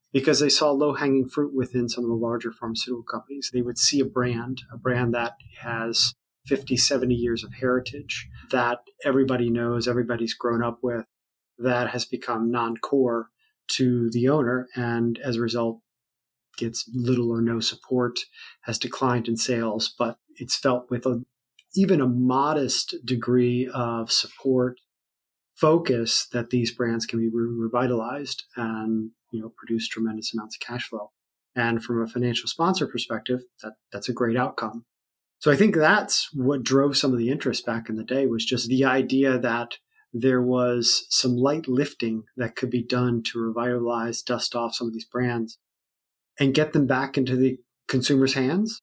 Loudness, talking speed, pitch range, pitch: -24 LUFS, 165 wpm, 115-130 Hz, 125 Hz